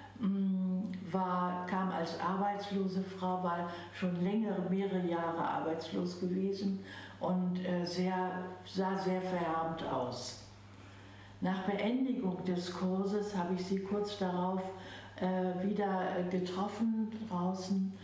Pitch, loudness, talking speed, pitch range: 185 Hz, -36 LUFS, 100 wpm, 180-195 Hz